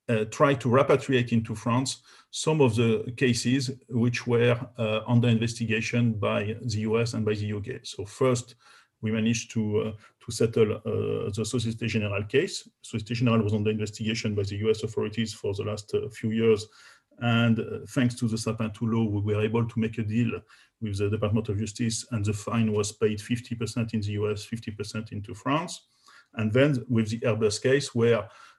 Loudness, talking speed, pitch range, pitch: -27 LUFS, 185 wpm, 110-120 Hz, 115 Hz